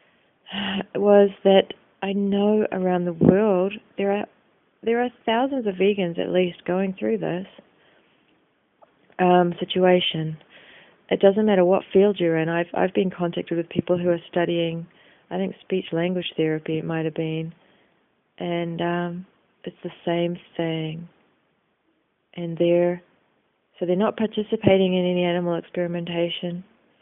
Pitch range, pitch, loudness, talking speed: 170-195 Hz, 180 Hz, -23 LUFS, 140 wpm